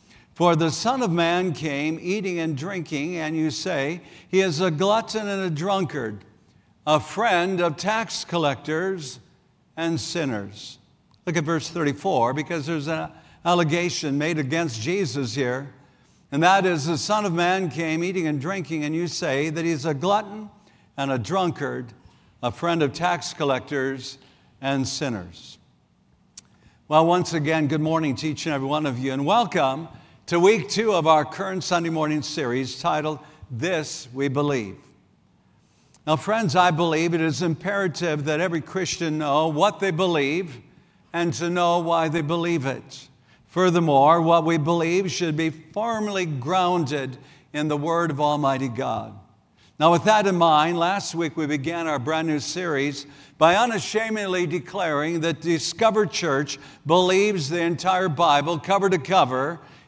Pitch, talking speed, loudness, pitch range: 165 Hz, 155 wpm, -23 LUFS, 145-180 Hz